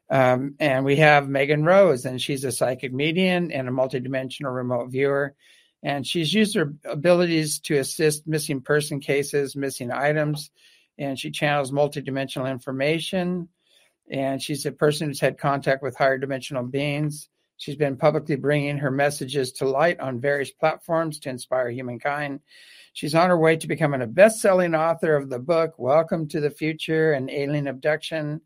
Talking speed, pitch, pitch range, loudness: 165 wpm, 145 Hz, 135-155 Hz, -23 LUFS